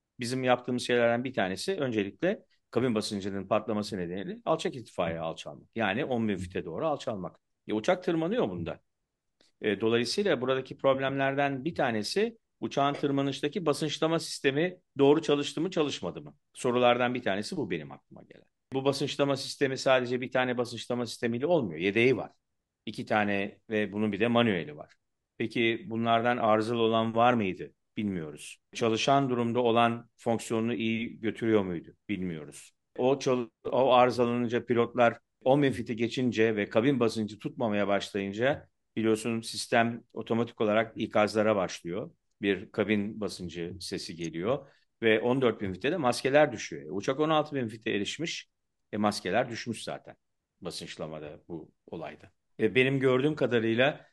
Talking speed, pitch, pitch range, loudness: 135 wpm, 120 Hz, 110-135 Hz, -29 LUFS